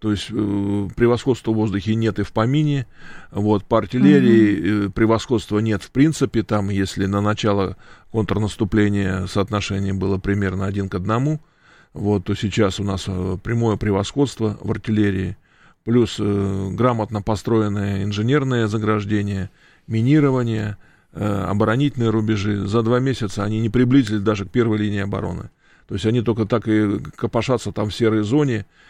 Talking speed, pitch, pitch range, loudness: 145 wpm, 105 Hz, 100-115 Hz, -20 LUFS